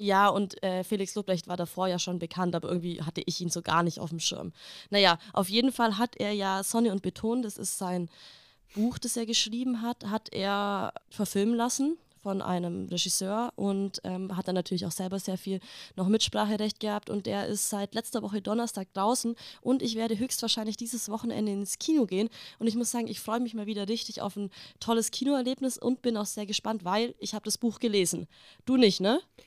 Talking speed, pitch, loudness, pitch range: 210 wpm, 210 Hz, -30 LUFS, 190-230 Hz